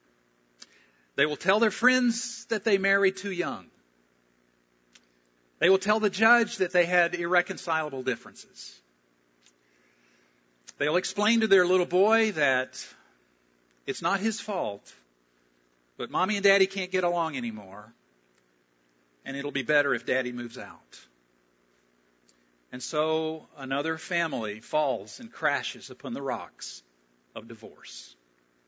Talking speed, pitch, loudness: 125 wpm, 115 Hz, -27 LUFS